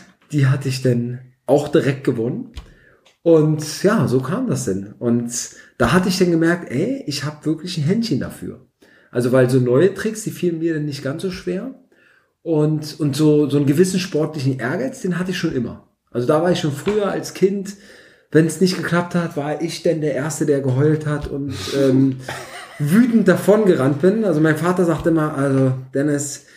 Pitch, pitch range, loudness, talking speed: 155 Hz, 140-180 Hz, -19 LUFS, 195 wpm